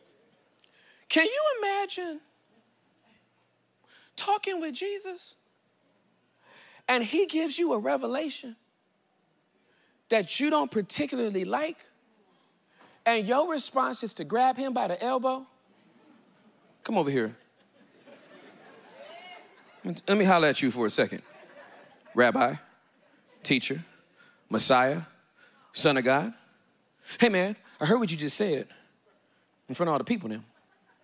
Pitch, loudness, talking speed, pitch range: 260 Hz, -27 LUFS, 115 wpm, 225-320 Hz